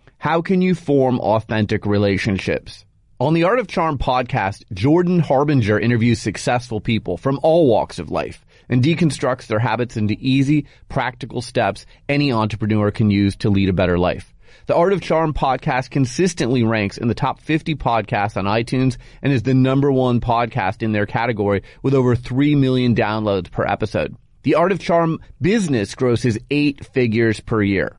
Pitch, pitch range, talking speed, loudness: 125 Hz, 110-140 Hz, 170 wpm, -19 LUFS